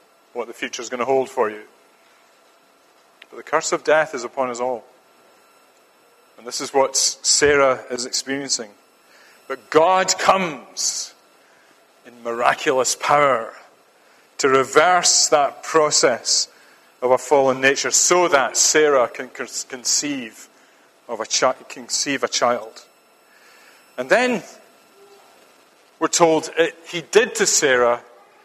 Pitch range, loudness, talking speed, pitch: 130-165 Hz, -18 LUFS, 125 wpm, 140 Hz